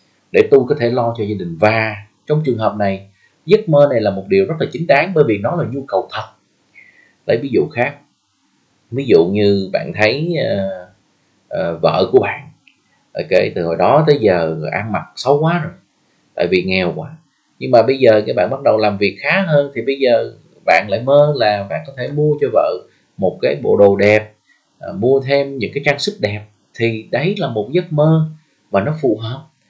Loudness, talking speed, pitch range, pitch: -15 LUFS, 215 wpm, 105-155 Hz, 140 Hz